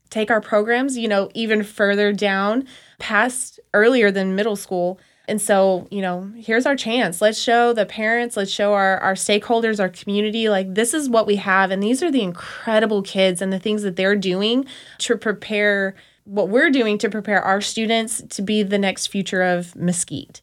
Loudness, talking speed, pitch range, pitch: -19 LUFS, 190 wpm, 195-225 Hz, 210 Hz